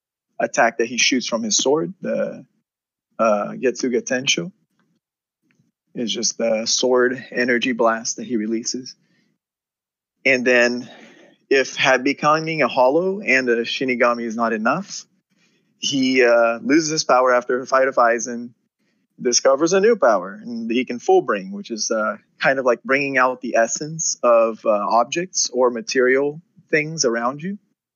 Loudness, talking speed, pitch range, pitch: -19 LUFS, 150 wpm, 120-190 Hz, 135 Hz